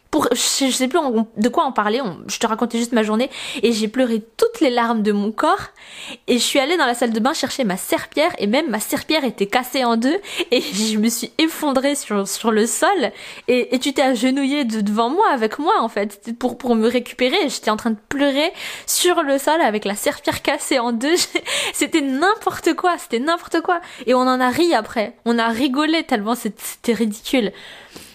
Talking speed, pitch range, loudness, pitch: 220 wpm, 230-310 Hz, -19 LUFS, 255 Hz